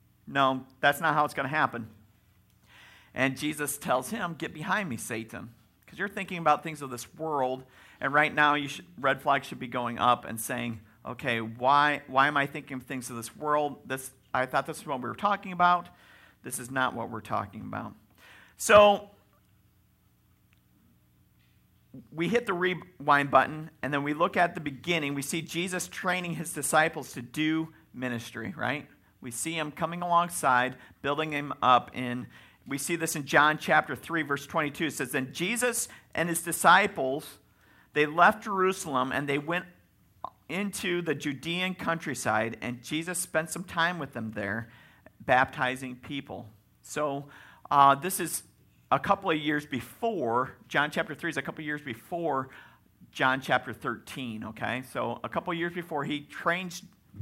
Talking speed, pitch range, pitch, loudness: 170 wpm, 125-170 Hz, 145 Hz, -28 LUFS